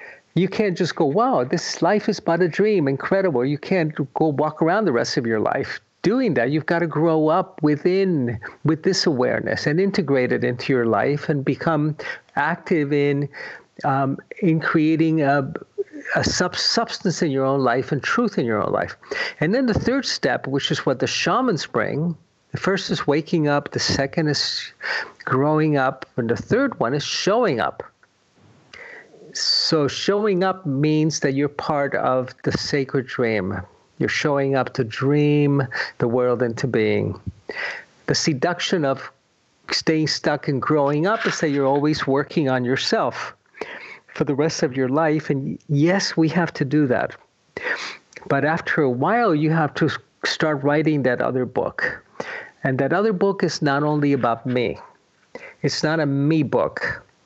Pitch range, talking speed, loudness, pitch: 135-170 Hz, 170 wpm, -21 LUFS, 150 Hz